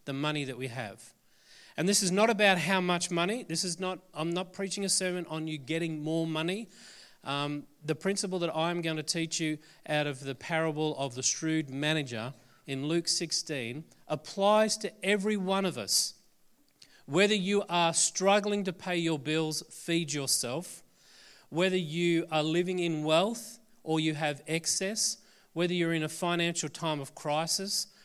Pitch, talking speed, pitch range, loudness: 165 Hz, 170 wpm, 155-185 Hz, -30 LUFS